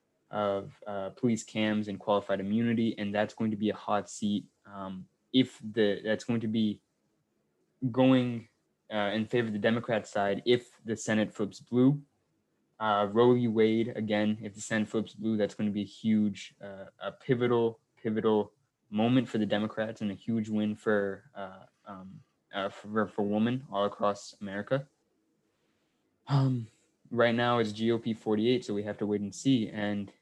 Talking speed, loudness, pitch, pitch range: 175 wpm, -30 LUFS, 110 Hz, 105-115 Hz